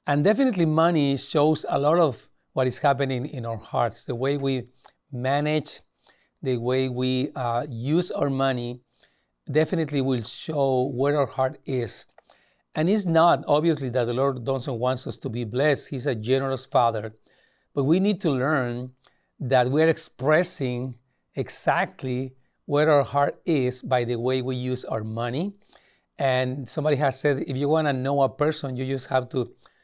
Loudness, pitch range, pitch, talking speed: -25 LUFS, 125-150 Hz, 135 Hz, 165 wpm